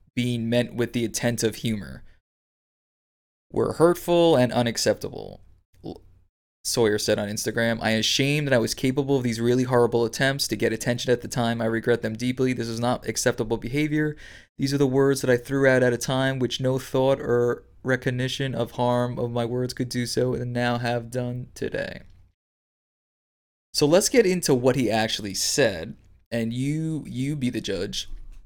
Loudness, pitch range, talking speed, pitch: -24 LUFS, 110-130 Hz, 175 wpm, 120 Hz